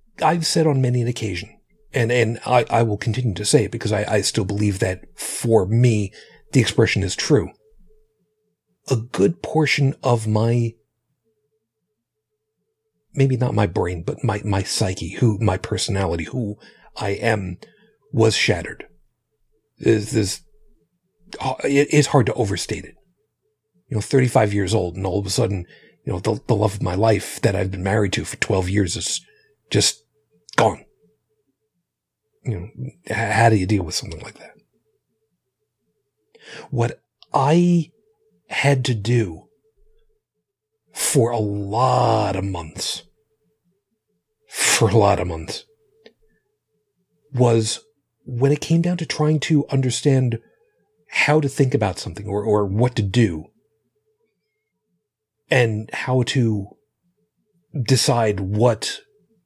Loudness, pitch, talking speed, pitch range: -20 LUFS, 115 Hz, 135 wpm, 105-145 Hz